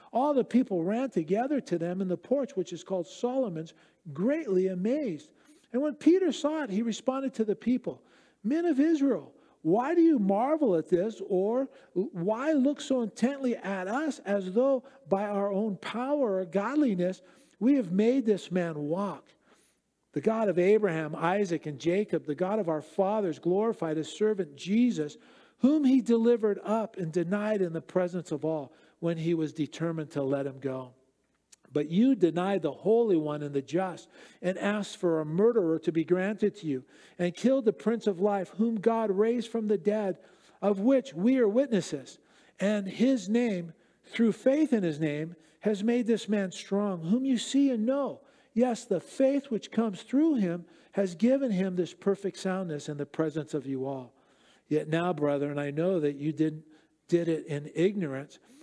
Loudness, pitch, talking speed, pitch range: -29 LUFS, 195 Hz, 180 wpm, 170-240 Hz